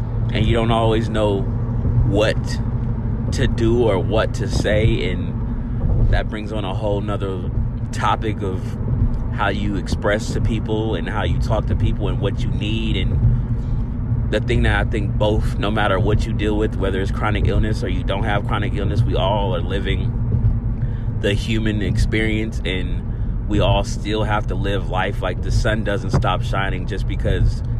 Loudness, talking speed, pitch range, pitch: -20 LUFS, 175 wpm, 105-115 Hz, 110 Hz